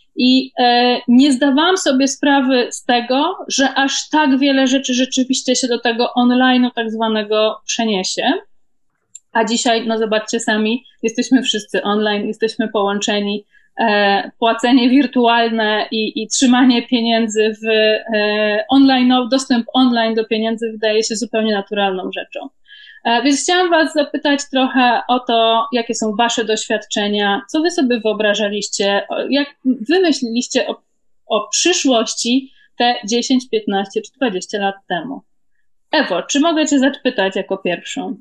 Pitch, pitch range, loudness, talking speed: 240 Hz, 215-265 Hz, -16 LUFS, 130 wpm